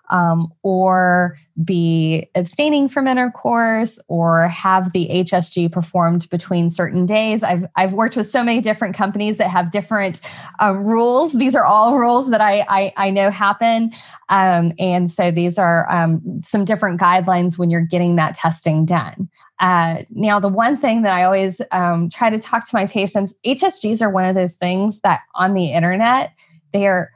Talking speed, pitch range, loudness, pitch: 175 wpm, 175-220 Hz, -17 LUFS, 190 Hz